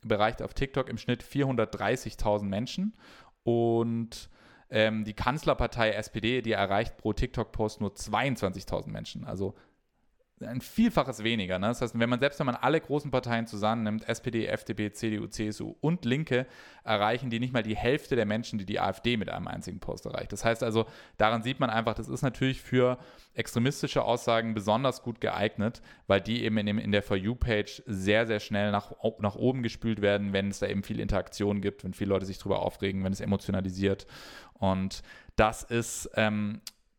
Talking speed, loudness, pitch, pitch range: 180 wpm, -30 LUFS, 110 Hz, 105-120 Hz